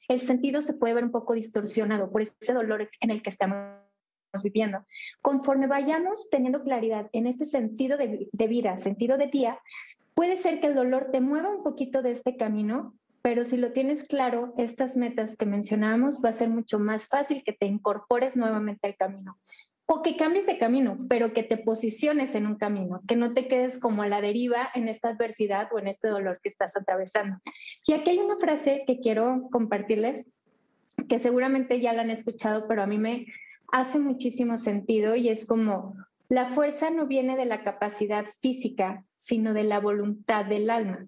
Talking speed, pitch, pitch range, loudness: 190 wpm, 235 Hz, 215-260 Hz, -27 LUFS